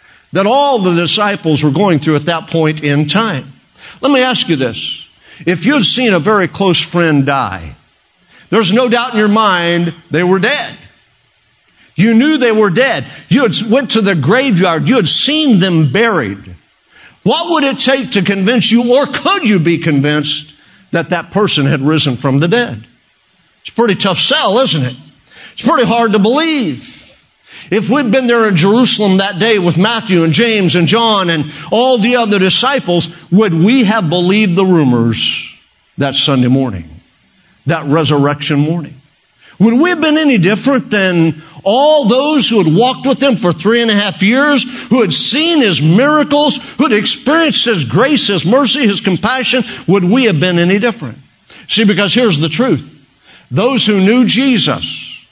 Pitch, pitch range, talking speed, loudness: 205 Hz, 165-240 Hz, 175 wpm, -11 LUFS